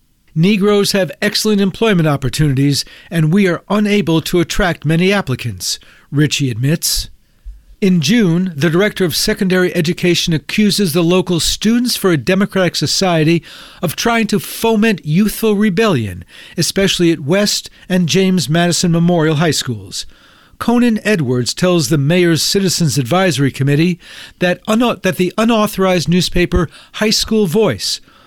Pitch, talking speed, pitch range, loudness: 180 Hz, 130 wpm, 160-205 Hz, -14 LUFS